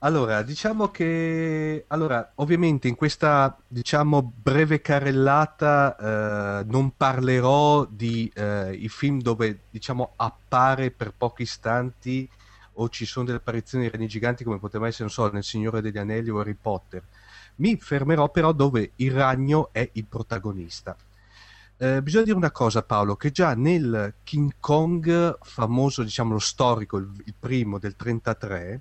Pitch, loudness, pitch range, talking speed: 120 Hz, -24 LUFS, 110-145 Hz, 150 wpm